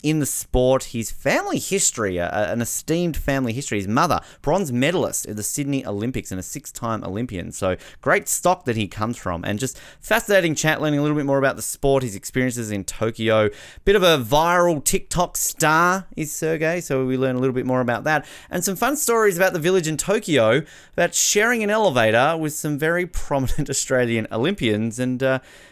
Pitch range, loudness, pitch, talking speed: 115-165 Hz, -21 LUFS, 140 Hz, 195 wpm